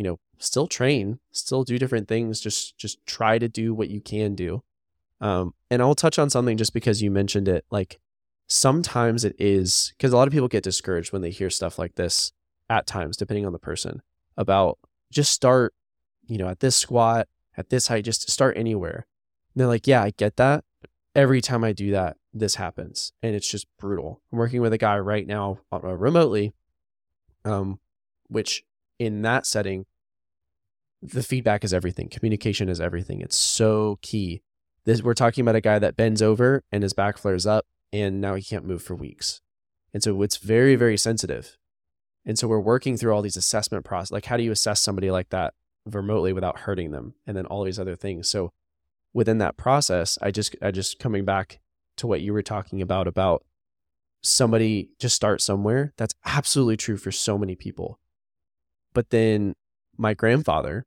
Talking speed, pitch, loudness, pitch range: 190 wpm, 105 Hz, -23 LUFS, 95-115 Hz